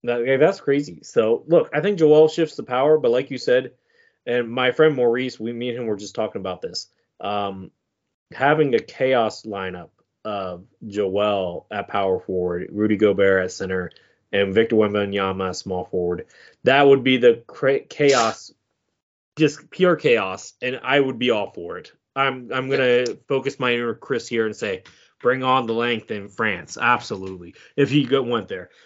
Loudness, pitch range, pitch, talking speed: -21 LUFS, 100-140 Hz, 120 Hz, 175 wpm